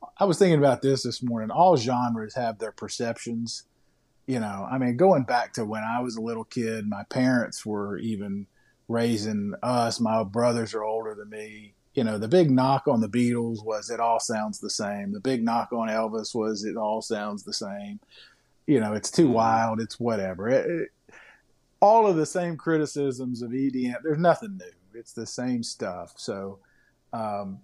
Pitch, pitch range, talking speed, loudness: 115 Hz, 110-130 Hz, 190 wpm, -26 LUFS